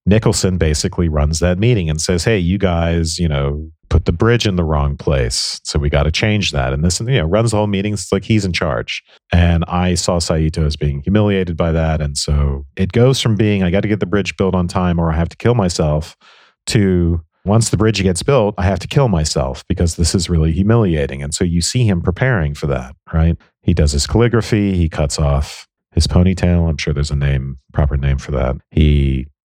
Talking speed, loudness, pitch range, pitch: 225 wpm, -16 LUFS, 75-100 Hz, 85 Hz